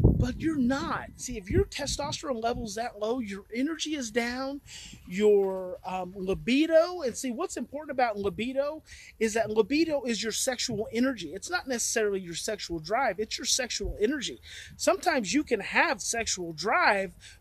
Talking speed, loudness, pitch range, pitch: 160 wpm, -29 LUFS, 210-275 Hz, 235 Hz